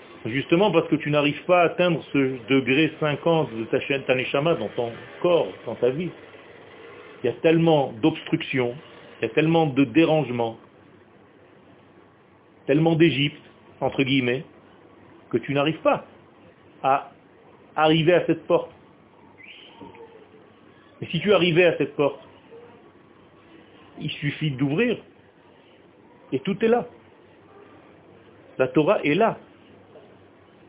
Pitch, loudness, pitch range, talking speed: 155 Hz, -22 LUFS, 135-170 Hz, 120 wpm